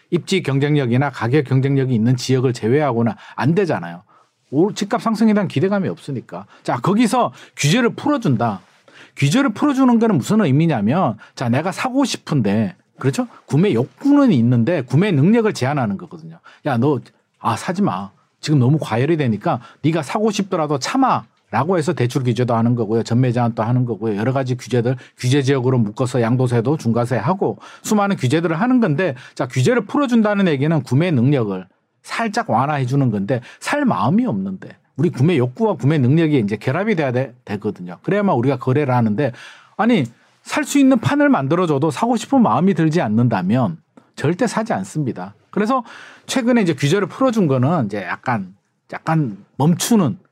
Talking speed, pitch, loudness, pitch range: 375 characters per minute, 150 Hz, -18 LUFS, 125-205 Hz